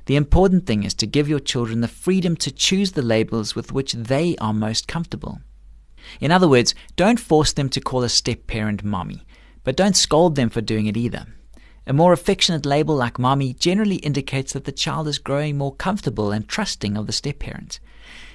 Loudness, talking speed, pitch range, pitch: -20 LUFS, 200 wpm, 110-160 Hz, 135 Hz